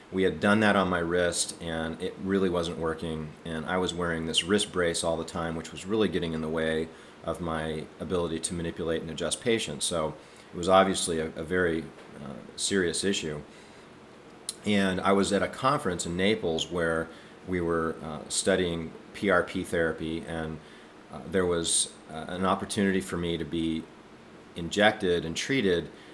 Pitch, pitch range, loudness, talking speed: 85 Hz, 80-95 Hz, -28 LUFS, 175 wpm